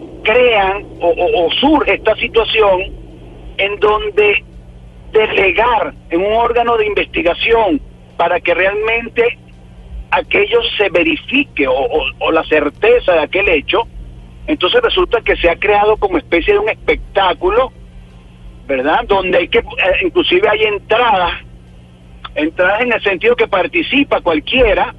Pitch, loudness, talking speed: 210 Hz, -13 LUFS, 130 wpm